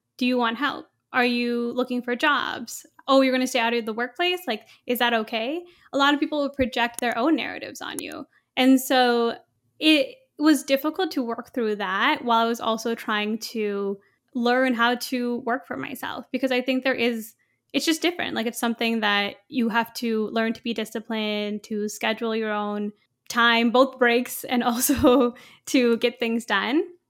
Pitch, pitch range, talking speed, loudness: 240 Hz, 230-265 Hz, 190 wpm, -23 LUFS